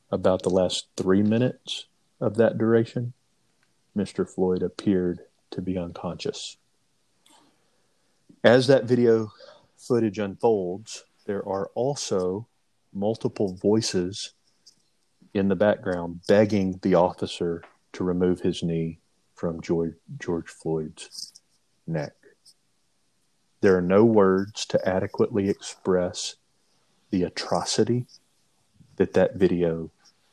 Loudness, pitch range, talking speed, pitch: -25 LUFS, 90-110 Hz, 100 wpm, 95 Hz